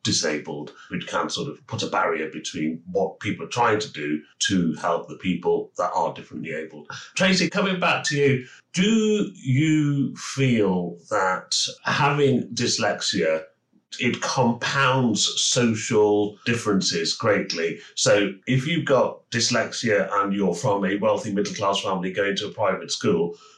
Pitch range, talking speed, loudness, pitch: 100-150 Hz, 145 wpm, -23 LUFS, 115 Hz